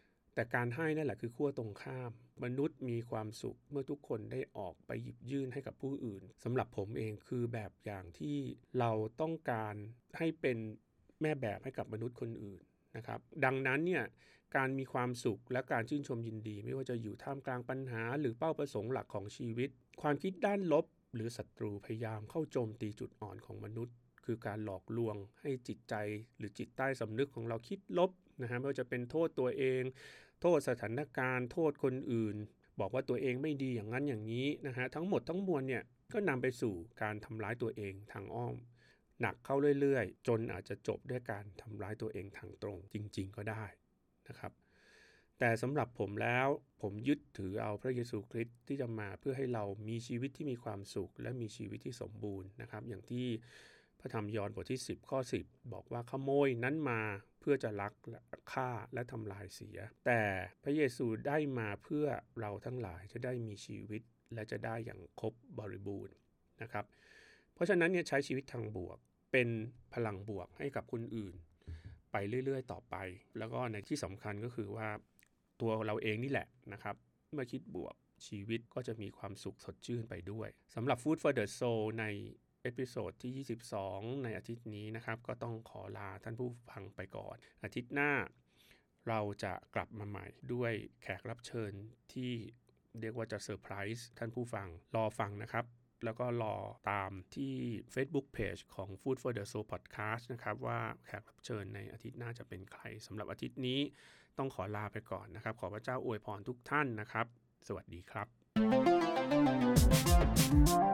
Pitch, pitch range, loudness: 115 Hz, 105-130 Hz, -39 LUFS